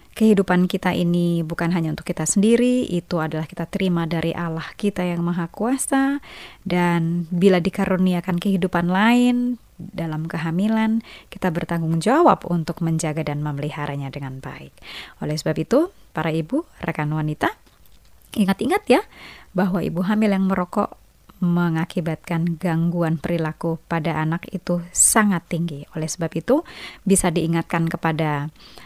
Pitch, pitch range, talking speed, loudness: 175 Hz, 165-195 Hz, 130 wpm, -21 LUFS